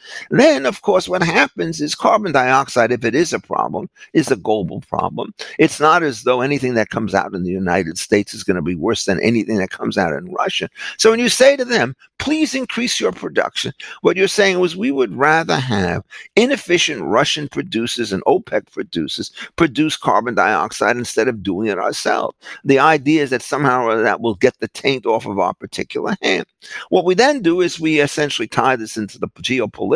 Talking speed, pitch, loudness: 200 wpm, 155 Hz, -17 LUFS